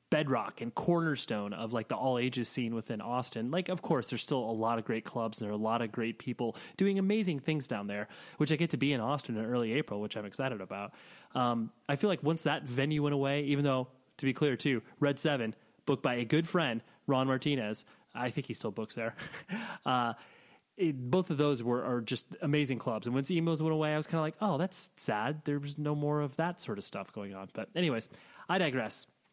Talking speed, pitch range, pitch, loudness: 235 wpm, 115-155 Hz, 140 Hz, -34 LUFS